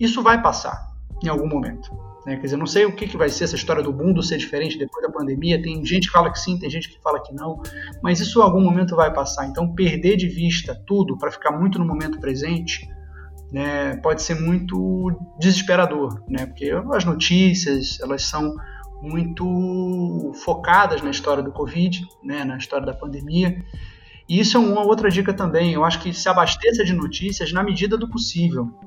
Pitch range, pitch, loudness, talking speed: 145-185 Hz, 170 Hz, -20 LUFS, 195 wpm